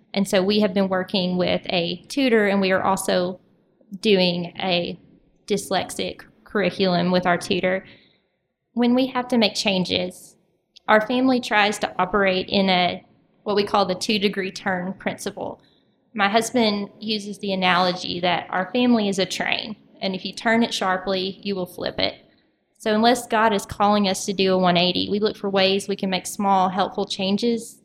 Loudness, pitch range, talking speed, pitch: -21 LUFS, 185-215 Hz, 175 wpm, 195 Hz